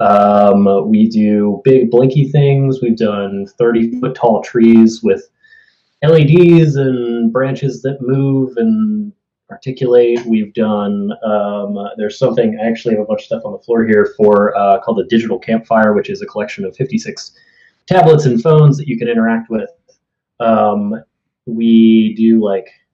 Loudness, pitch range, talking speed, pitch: -12 LUFS, 110-135 Hz, 155 wpm, 115 Hz